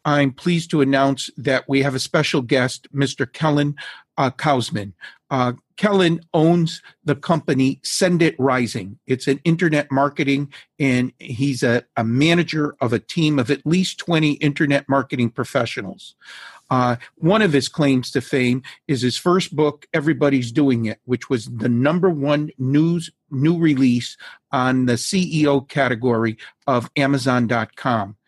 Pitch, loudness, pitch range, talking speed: 140 Hz, -20 LUFS, 125-155 Hz, 145 wpm